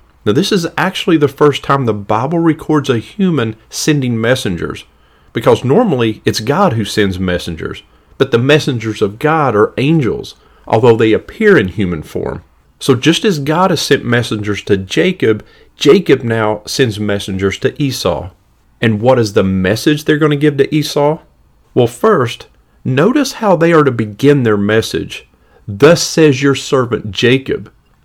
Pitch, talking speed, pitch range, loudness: 130 Hz, 160 wpm, 110-155 Hz, -13 LUFS